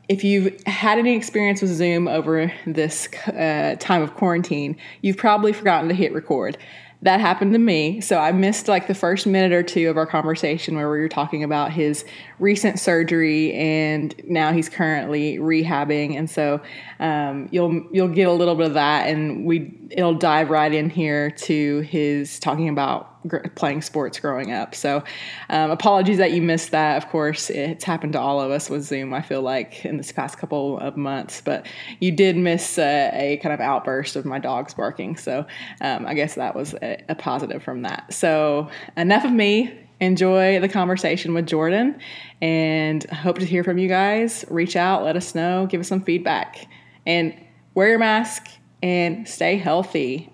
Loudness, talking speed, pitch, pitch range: -21 LUFS, 185 wpm, 165 Hz, 155-185 Hz